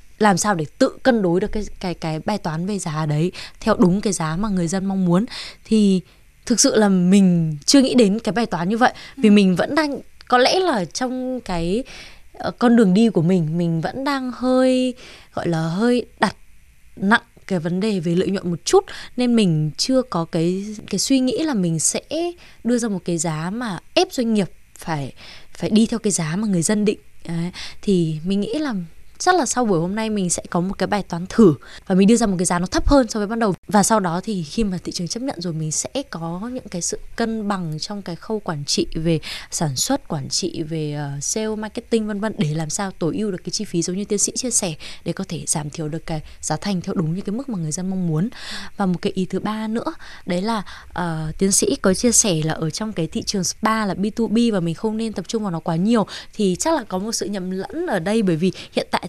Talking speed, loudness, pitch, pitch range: 250 wpm, -20 LUFS, 195 Hz, 175-225 Hz